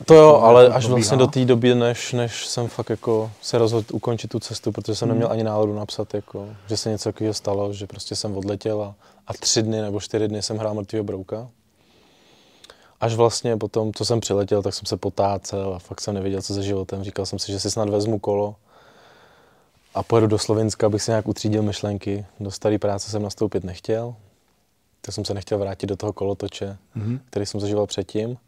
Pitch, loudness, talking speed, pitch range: 105 Hz, -21 LUFS, 205 wpm, 100-115 Hz